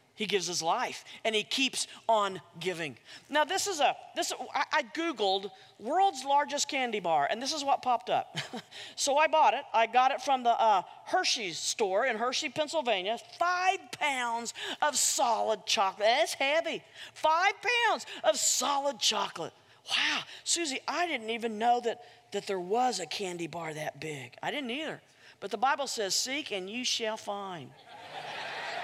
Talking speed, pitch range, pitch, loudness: 170 wpm, 210-315 Hz, 255 Hz, -30 LUFS